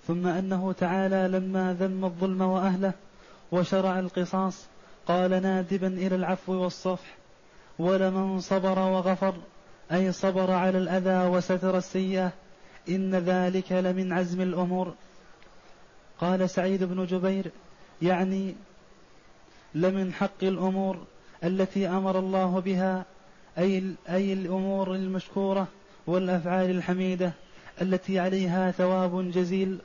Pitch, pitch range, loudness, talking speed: 185 Hz, 185-190 Hz, -27 LUFS, 100 wpm